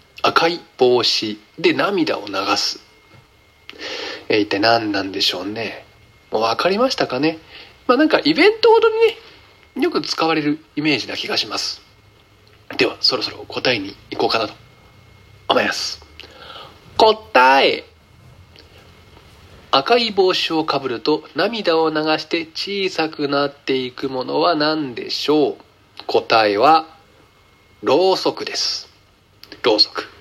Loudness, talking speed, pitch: -18 LUFS, 240 characters per minute, 155 Hz